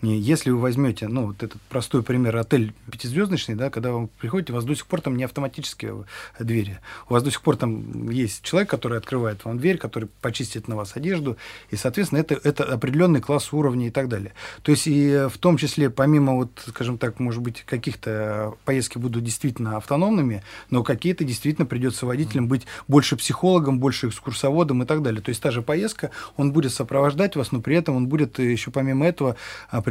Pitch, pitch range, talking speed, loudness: 130 Hz, 115-145 Hz, 195 wpm, -23 LUFS